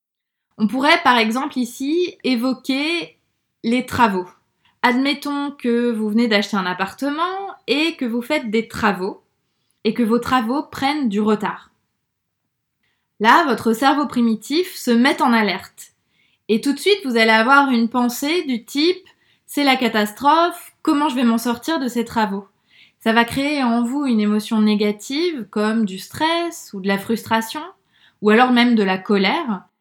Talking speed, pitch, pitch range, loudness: 160 wpm, 240 Hz, 215-285 Hz, -18 LUFS